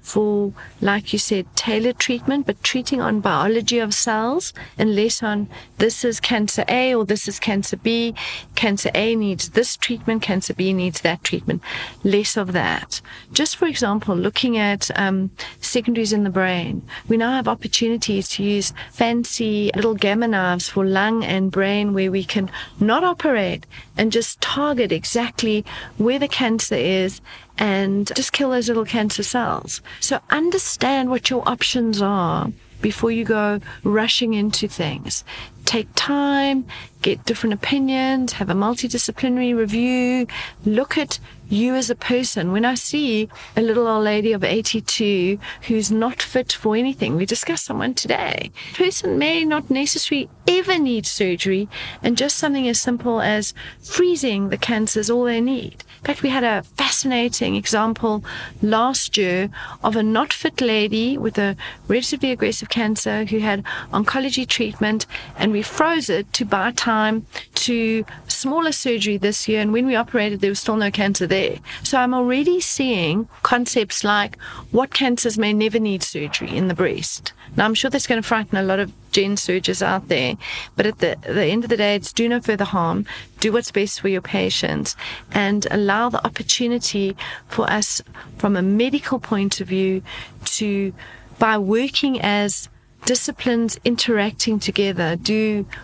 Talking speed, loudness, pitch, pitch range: 165 wpm, -19 LUFS, 220 Hz, 200-245 Hz